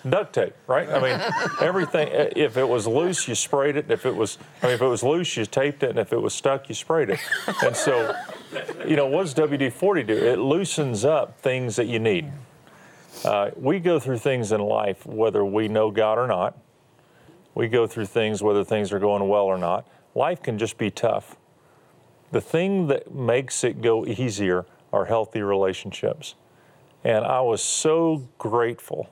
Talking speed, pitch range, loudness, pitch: 190 wpm, 105-140 Hz, -23 LUFS, 115 Hz